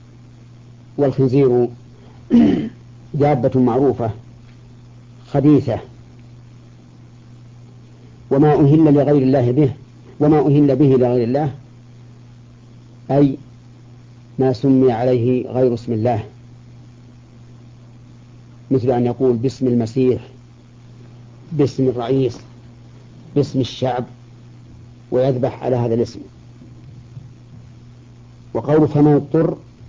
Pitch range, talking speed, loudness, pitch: 120-130 Hz, 75 wpm, -17 LUFS, 120 Hz